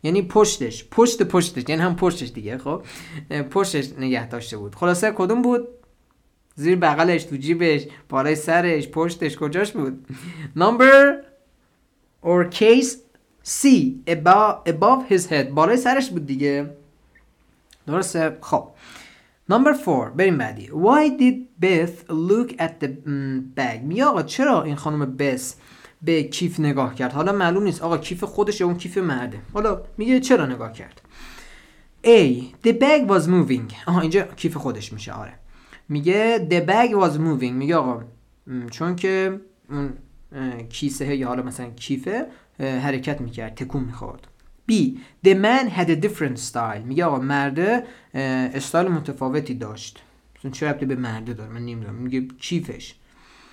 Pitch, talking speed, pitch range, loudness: 160 Hz, 140 wpm, 130-195 Hz, -20 LUFS